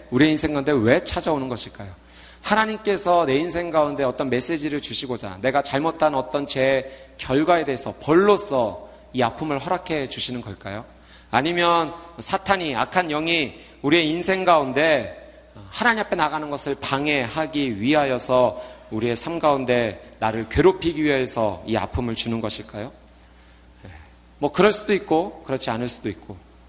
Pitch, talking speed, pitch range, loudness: 140 Hz, 330 characters per minute, 115-165 Hz, -22 LUFS